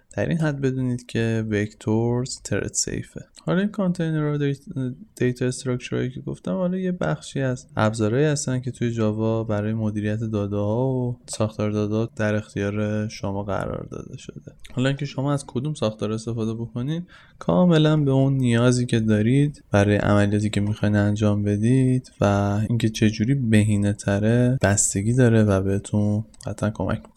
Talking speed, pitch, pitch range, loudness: 150 wpm, 115 Hz, 105-130 Hz, -23 LUFS